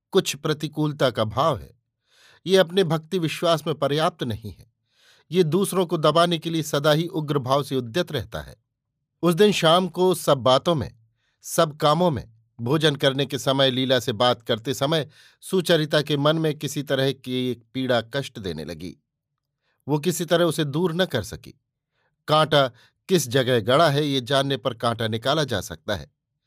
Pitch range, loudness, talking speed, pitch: 125-165 Hz, -22 LUFS, 180 wpm, 145 Hz